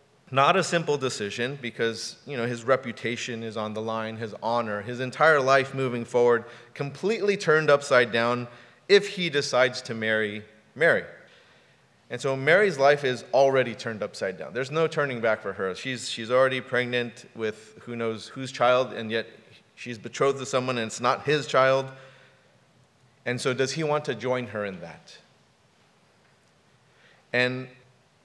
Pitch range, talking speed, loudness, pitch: 115-135 Hz, 160 wpm, -25 LUFS, 125 Hz